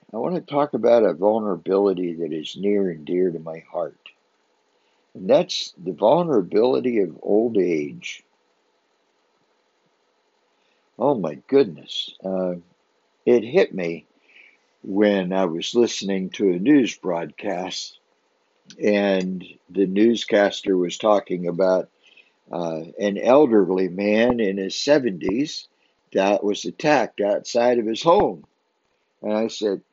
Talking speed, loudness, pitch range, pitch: 120 wpm, -21 LUFS, 95-120 Hz, 100 Hz